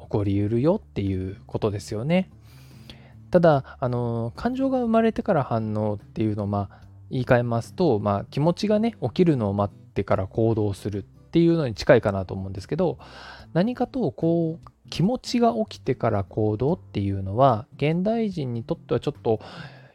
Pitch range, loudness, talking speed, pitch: 105-165 Hz, -24 LUFS, 355 characters per minute, 120 Hz